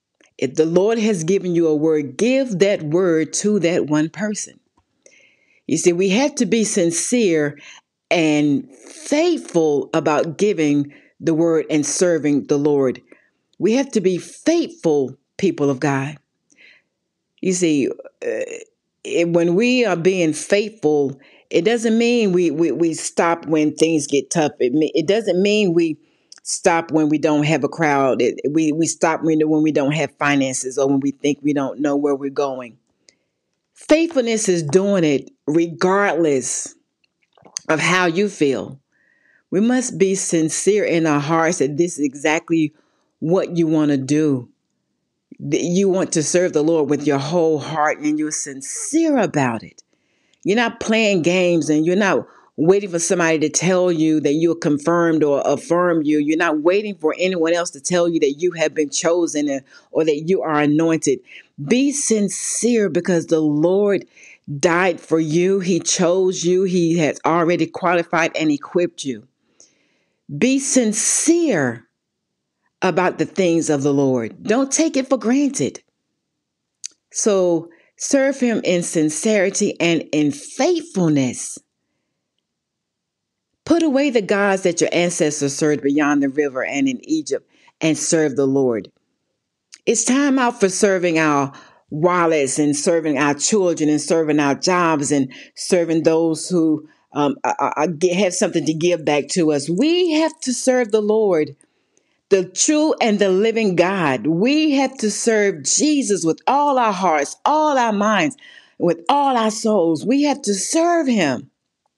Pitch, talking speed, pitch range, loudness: 170 Hz, 155 wpm, 150-210 Hz, -18 LUFS